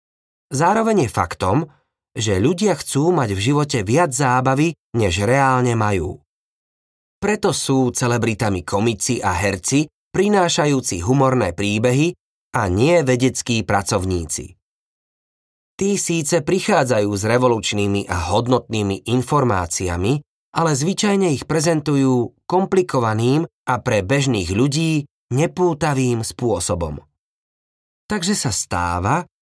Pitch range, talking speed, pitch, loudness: 100-160 Hz, 100 wpm, 125 Hz, -19 LUFS